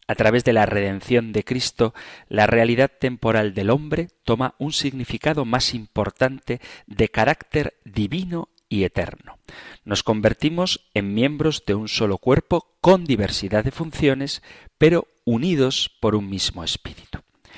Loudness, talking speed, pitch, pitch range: -21 LUFS, 135 wpm, 120 Hz, 105-140 Hz